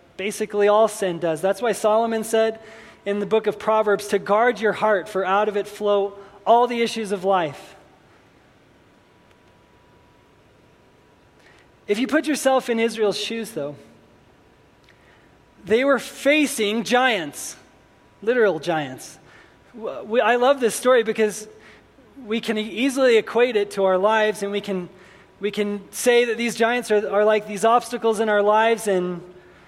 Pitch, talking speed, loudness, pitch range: 215 Hz, 150 wpm, -21 LUFS, 205-230 Hz